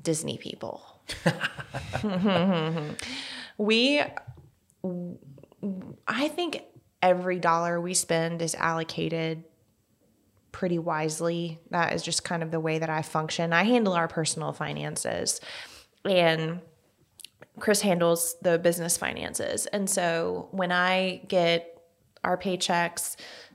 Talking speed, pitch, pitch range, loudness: 105 wpm, 170 Hz, 160-185 Hz, -27 LUFS